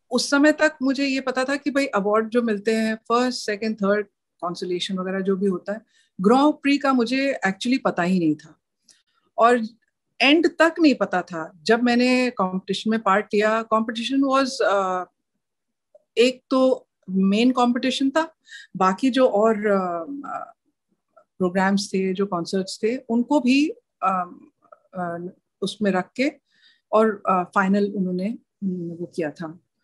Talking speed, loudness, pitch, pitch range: 135 wpm, -22 LUFS, 220 Hz, 190-265 Hz